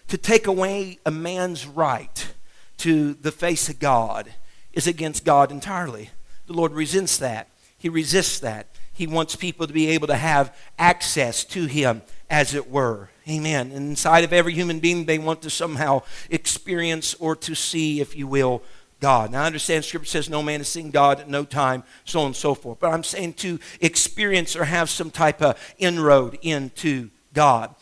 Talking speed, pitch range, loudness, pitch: 185 wpm, 140-170 Hz, -22 LUFS, 155 Hz